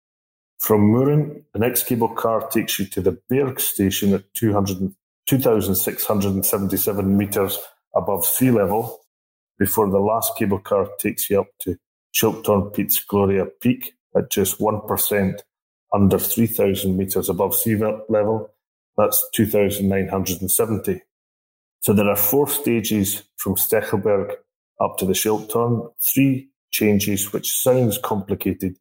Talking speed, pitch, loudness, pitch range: 135 wpm, 105 Hz, -20 LUFS, 95-115 Hz